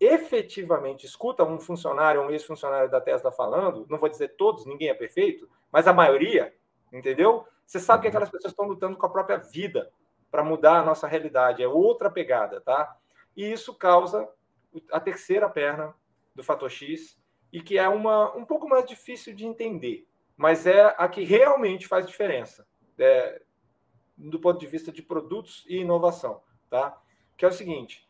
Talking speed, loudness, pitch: 170 wpm, -24 LUFS, 195 Hz